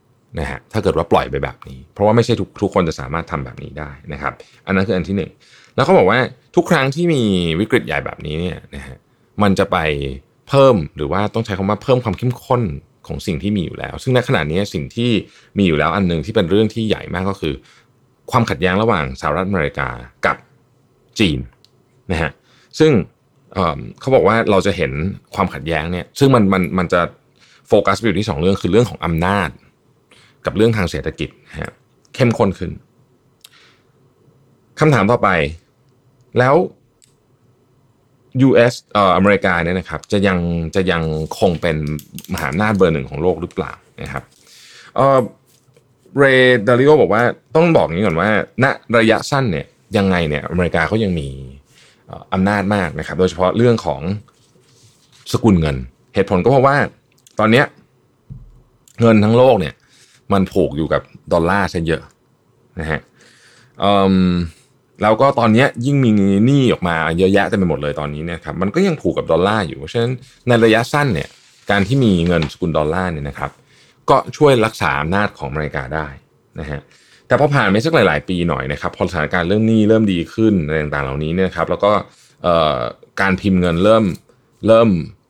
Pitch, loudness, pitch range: 100 Hz, -16 LUFS, 85-125 Hz